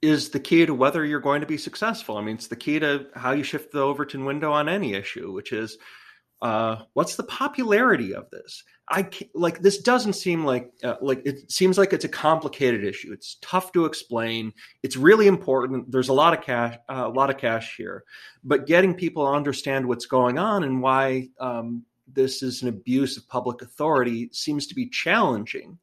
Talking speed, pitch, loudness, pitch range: 205 wpm, 140 Hz, -23 LUFS, 125-165 Hz